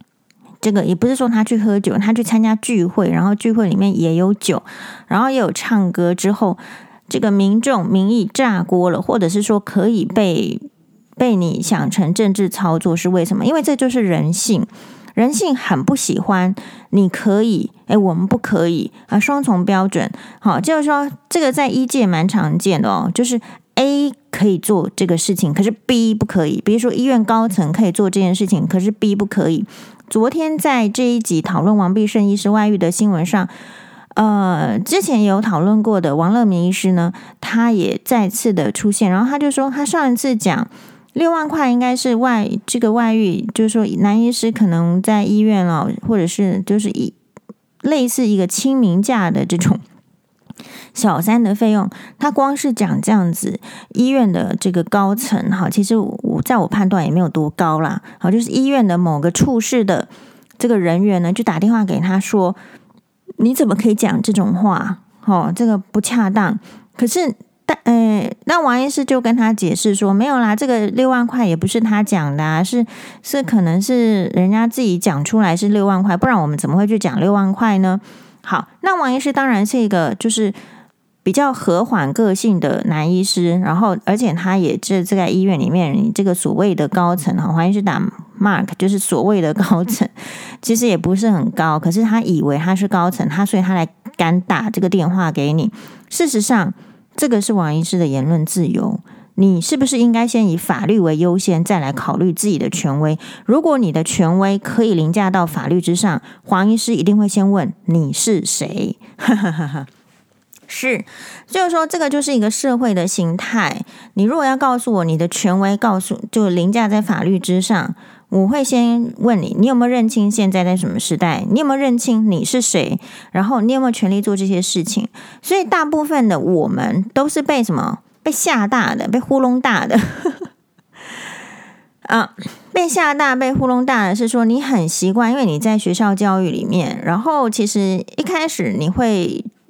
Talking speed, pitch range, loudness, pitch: 275 characters per minute, 190-235 Hz, -16 LUFS, 210 Hz